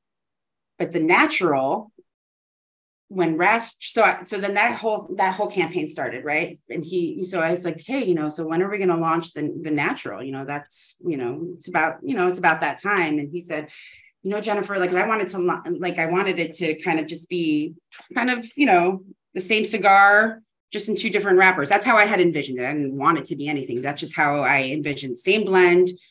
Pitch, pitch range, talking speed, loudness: 180 Hz, 160-205 Hz, 225 wpm, -21 LUFS